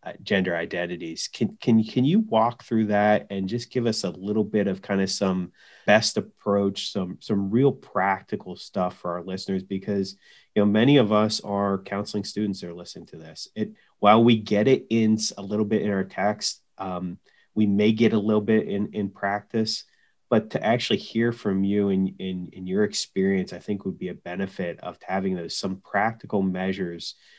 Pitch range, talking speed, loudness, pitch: 95-110 Hz, 200 wpm, -25 LUFS, 100 Hz